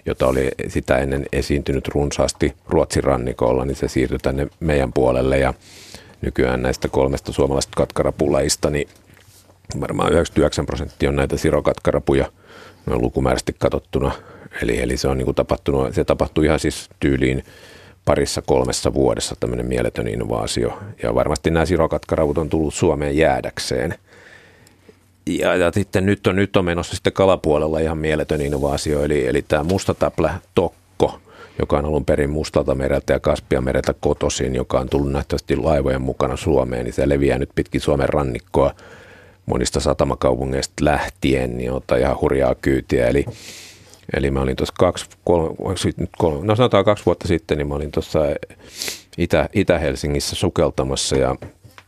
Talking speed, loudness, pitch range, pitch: 140 wpm, -20 LUFS, 65-80 Hz, 70 Hz